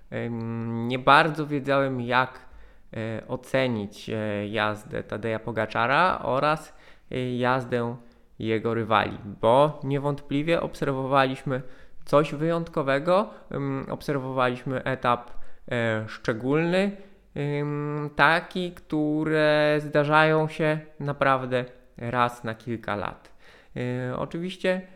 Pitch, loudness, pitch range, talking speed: 135 Hz, -25 LUFS, 120-150 Hz, 70 wpm